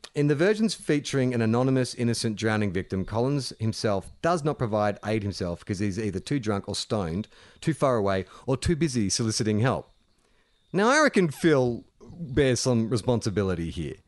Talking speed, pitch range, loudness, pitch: 165 wpm, 105-145 Hz, -26 LUFS, 120 Hz